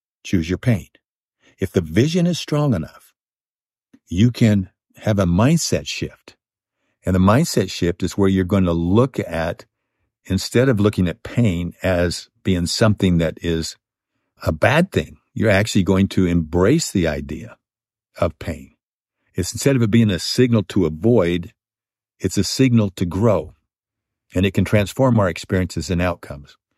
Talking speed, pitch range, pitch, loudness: 155 wpm, 90-115 Hz, 95 Hz, -19 LUFS